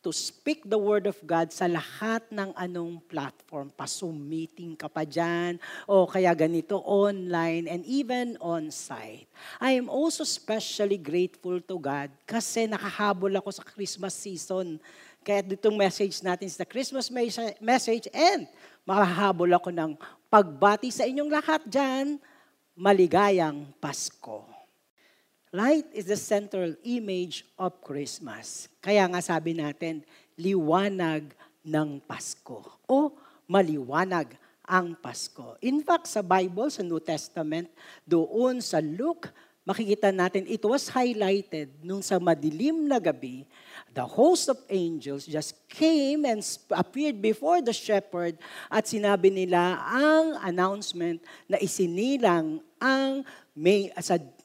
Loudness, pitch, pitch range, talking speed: -27 LUFS, 195 Hz, 170-230 Hz, 125 wpm